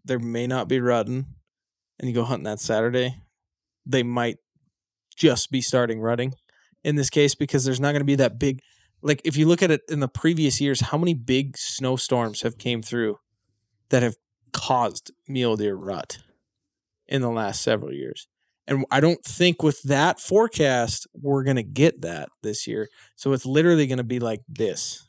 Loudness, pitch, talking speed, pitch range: -23 LUFS, 130 Hz, 185 wpm, 120-145 Hz